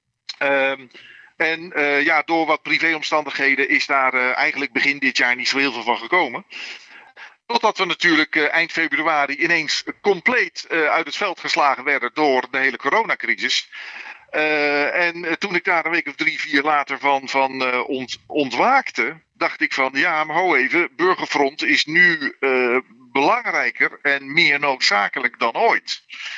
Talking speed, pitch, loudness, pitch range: 160 wpm, 145 Hz, -18 LUFS, 135-165 Hz